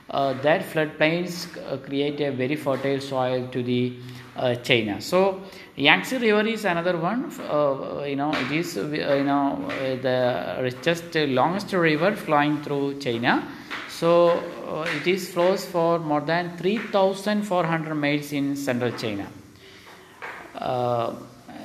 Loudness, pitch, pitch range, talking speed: -24 LUFS, 150 Hz, 130-175 Hz, 140 wpm